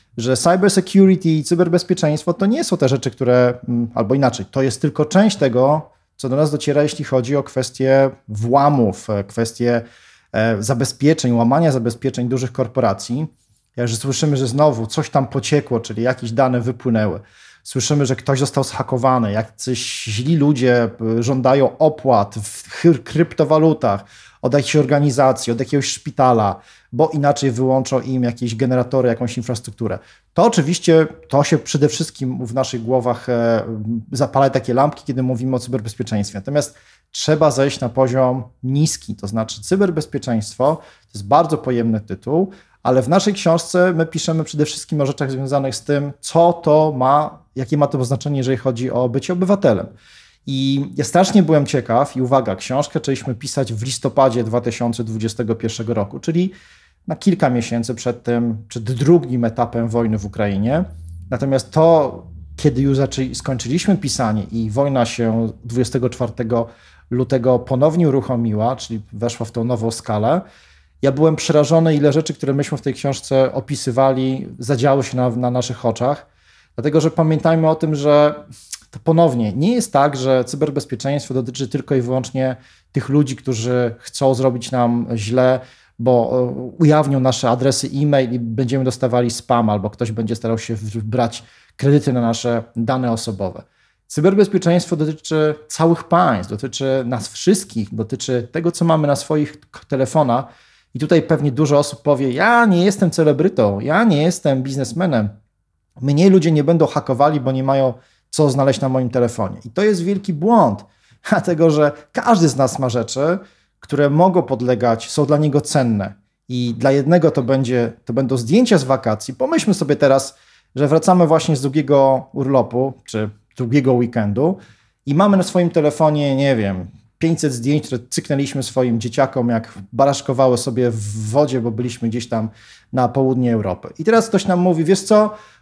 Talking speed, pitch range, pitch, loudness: 155 wpm, 120-150 Hz, 130 Hz, -17 LUFS